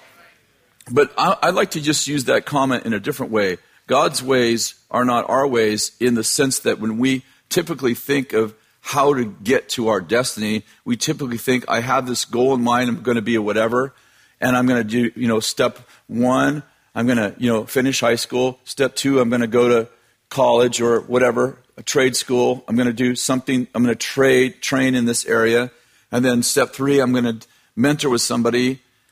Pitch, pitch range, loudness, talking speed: 125 Hz, 120-130 Hz, -19 LUFS, 195 wpm